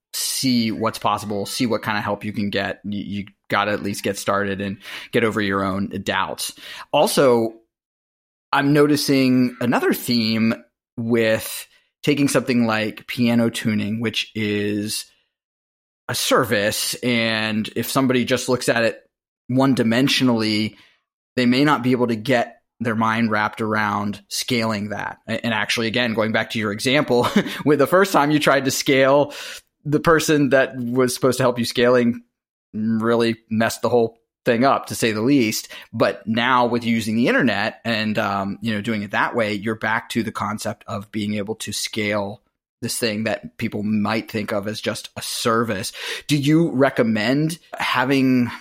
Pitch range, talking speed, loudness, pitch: 105-125 Hz, 170 wpm, -20 LUFS, 115 Hz